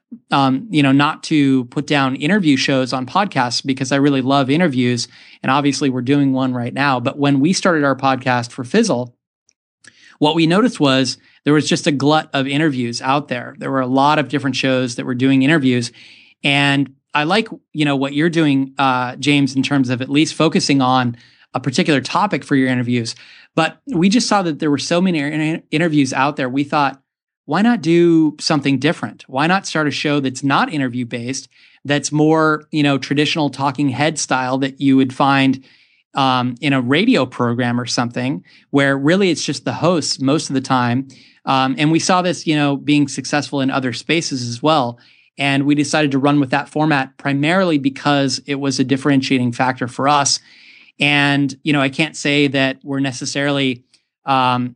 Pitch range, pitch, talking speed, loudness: 130-150 Hz, 140 Hz, 195 wpm, -17 LUFS